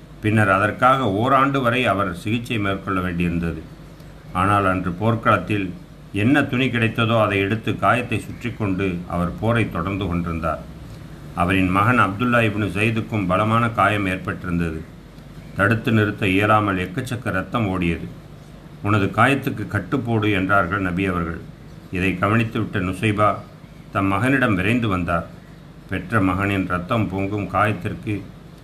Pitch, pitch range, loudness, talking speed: 105 Hz, 95-115 Hz, -20 LUFS, 115 wpm